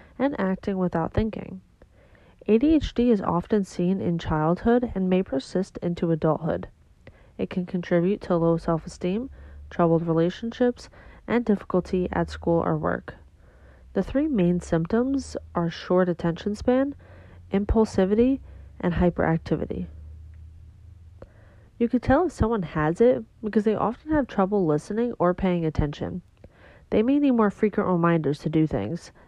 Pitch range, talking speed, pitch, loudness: 165-220 Hz, 135 wpm, 180 Hz, -25 LUFS